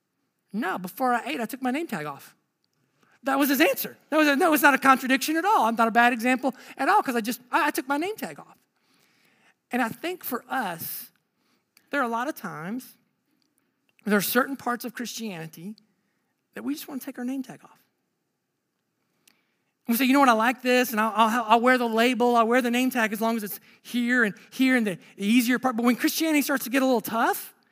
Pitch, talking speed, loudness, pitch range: 250 Hz, 235 wpm, -24 LUFS, 230-275 Hz